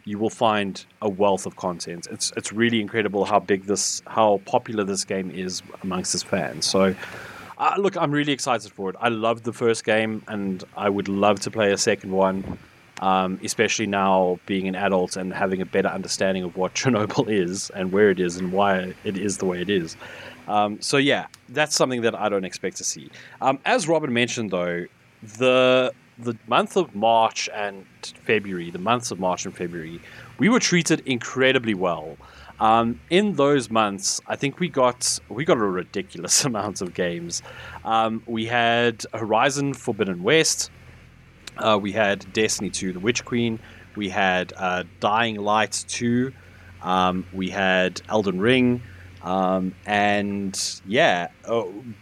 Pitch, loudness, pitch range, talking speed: 105 Hz, -23 LUFS, 95-120 Hz, 170 wpm